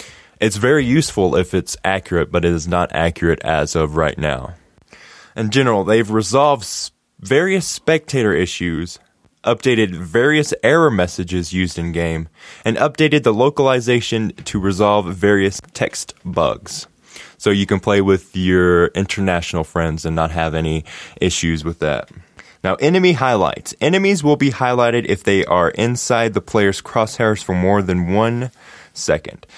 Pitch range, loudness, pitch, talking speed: 85-120 Hz, -17 LUFS, 100 Hz, 145 wpm